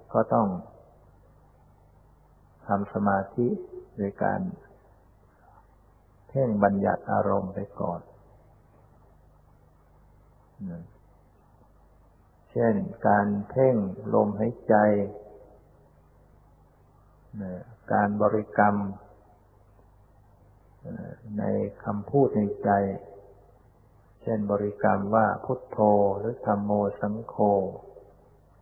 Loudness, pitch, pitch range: -26 LUFS, 105 Hz, 100-110 Hz